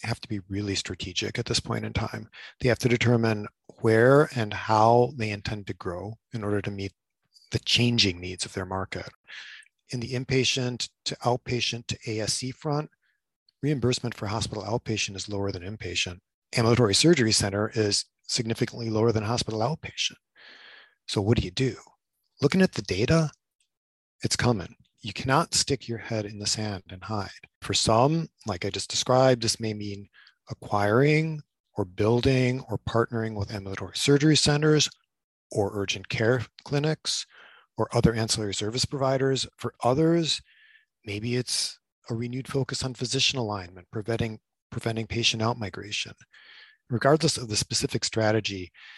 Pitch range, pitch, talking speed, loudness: 105-125 Hz, 115 Hz, 150 wpm, -26 LUFS